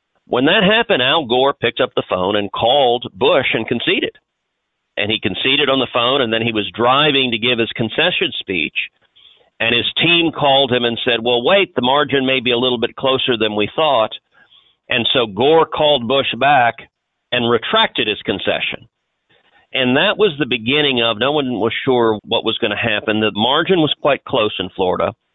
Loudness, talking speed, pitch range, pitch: -15 LUFS, 195 wpm, 115-140 Hz, 125 Hz